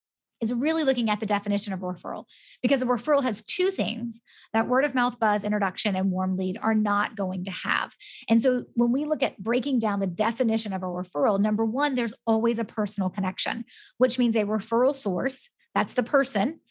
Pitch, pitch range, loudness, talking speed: 225 Hz, 205-250 Hz, -26 LUFS, 205 wpm